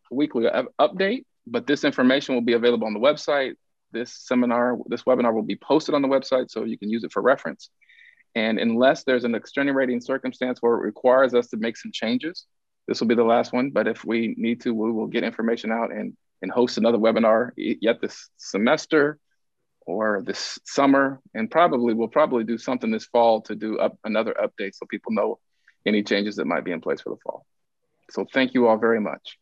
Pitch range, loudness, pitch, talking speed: 115-135 Hz, -23 LUFS, 120 Hz, 210 wpm